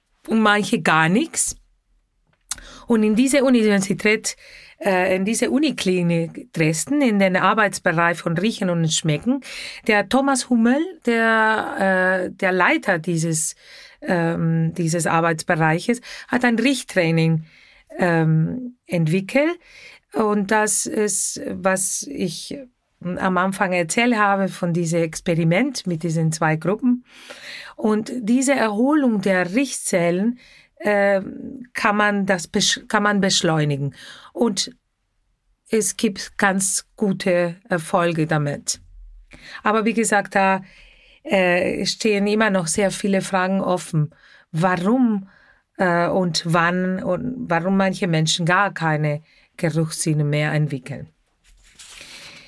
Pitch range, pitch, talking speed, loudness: 170-225 Hz, 195 Hz, 110 wpm, -20 LUFS